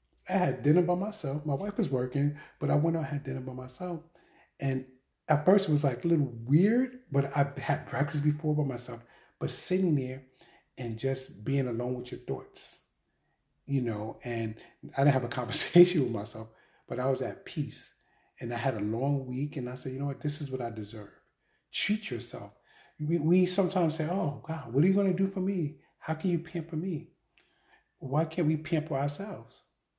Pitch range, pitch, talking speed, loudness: 130-170 Hz, 145 Hz, 205 wpm, -30 LUFS